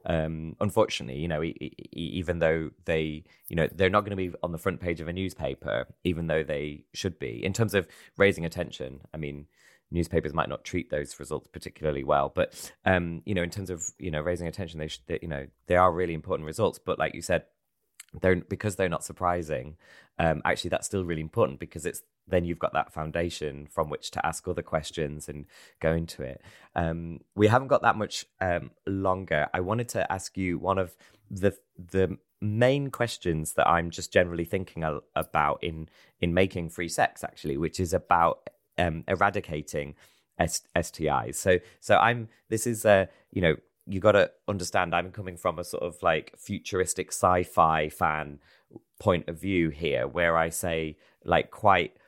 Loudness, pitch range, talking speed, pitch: -28 LUFS, 80-95 Hz, 190 wpm, 85 Hz